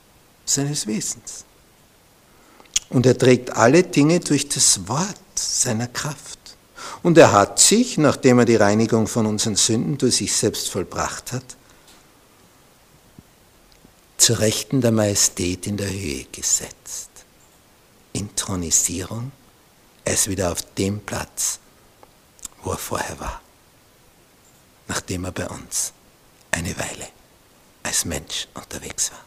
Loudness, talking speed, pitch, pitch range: -19 LUFS, 115 wpm, 110 Hz, 100-130 Hz